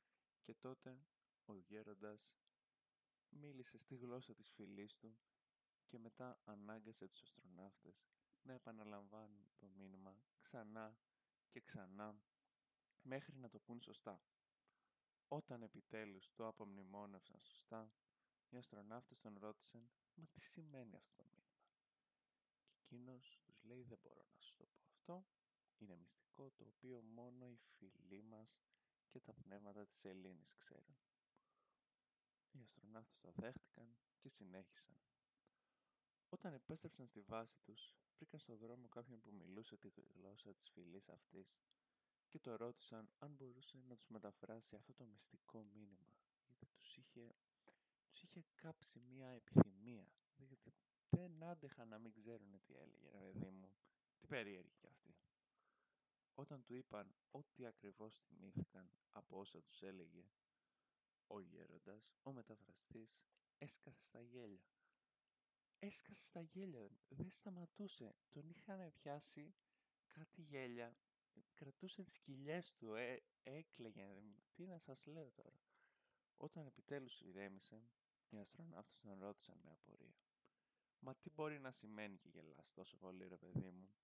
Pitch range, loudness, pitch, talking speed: 105-135 Hz, -56 LUFS, 120 Hz, 130 wpm